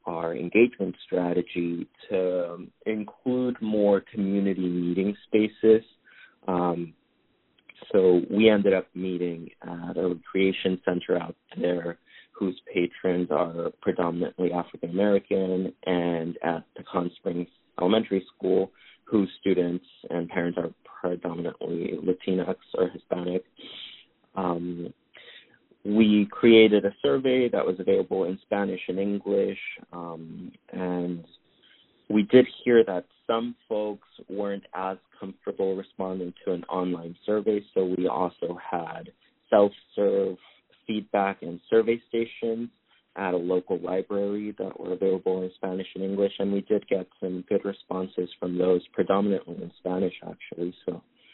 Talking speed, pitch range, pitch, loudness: 125 wpm, 90-105 Hz, 95 Hz, -26 LUFS